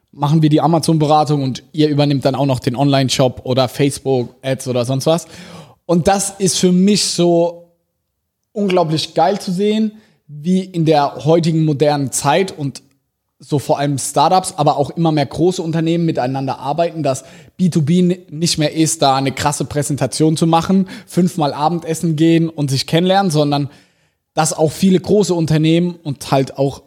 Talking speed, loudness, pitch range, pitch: 160 wpm, -16 LUFS, 140-170 Hz, 155 Hz